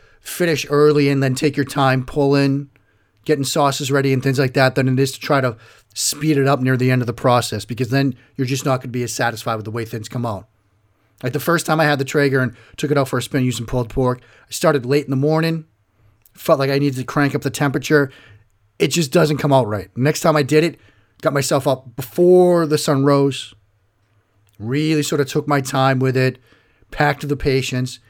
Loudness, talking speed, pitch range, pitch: -18 LUFS, 230 wpm, 120-145 Hz, 135 Hz